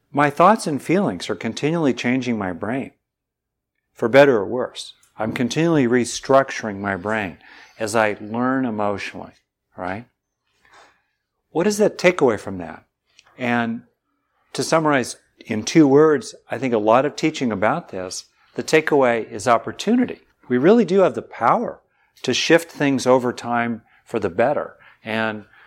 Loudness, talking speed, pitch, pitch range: -20 LUFS, 145 wpm, 125 Hz, 110-150 Hz